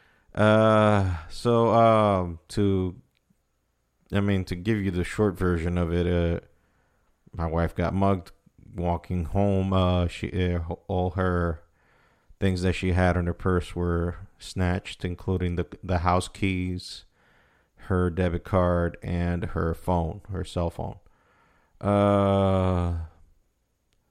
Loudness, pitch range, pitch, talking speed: -26 LUFS, 85-95 Hz, 90 Hz, 125 wpm